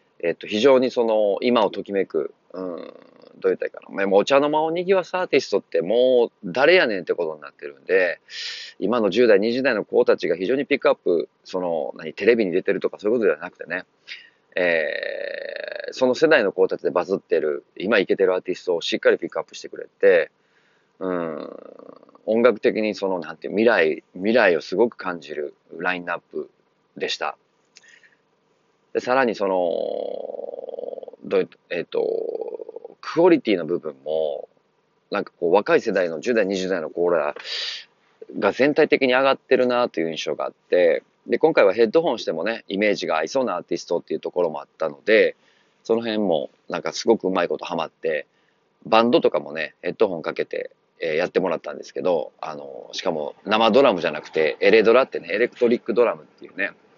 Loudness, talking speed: -22 LUFS, 365 characters per minute